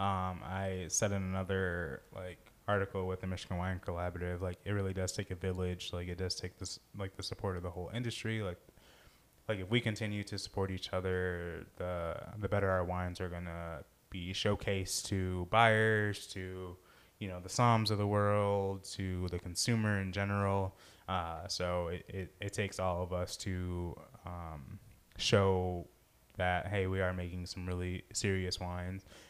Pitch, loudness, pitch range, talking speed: 95 Hz, -36 LUFS, 90-100 Hz, 175 wpm